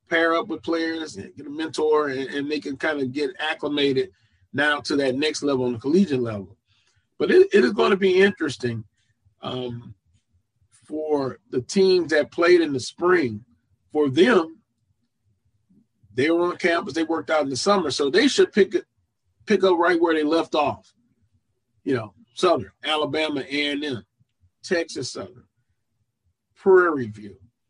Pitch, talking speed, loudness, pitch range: 140 Hz, 160 wpm, -22 LUFS, 115-165 Hz